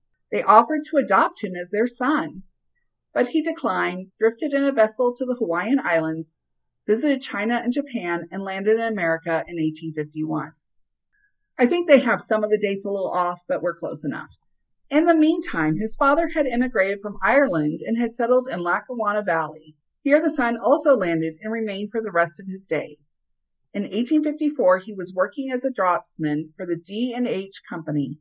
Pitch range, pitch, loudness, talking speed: 170-255 Hz, 210 Hz, -22 LUFS, 190 wpm